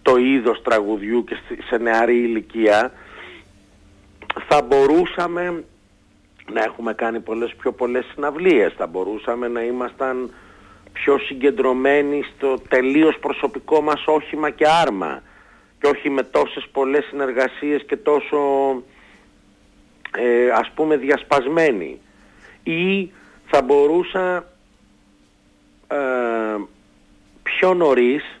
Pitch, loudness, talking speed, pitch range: 125 Hz, -19 LUFS, 100 wpm, 105-145 Hz